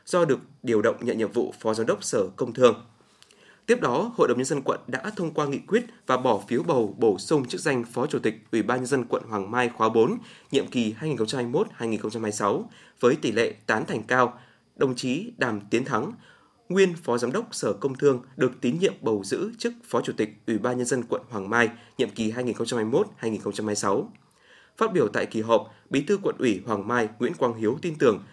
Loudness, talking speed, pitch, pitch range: -26 LUFS, 215 wpm, 125 Hz, 110-140 Hz